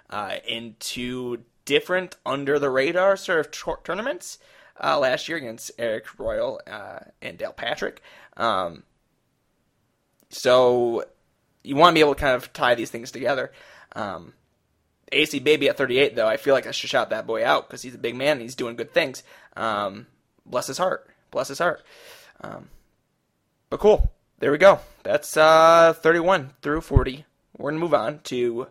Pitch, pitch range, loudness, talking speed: 150 Hz, 130-170 Hz, -22 LUFS, 175 wpm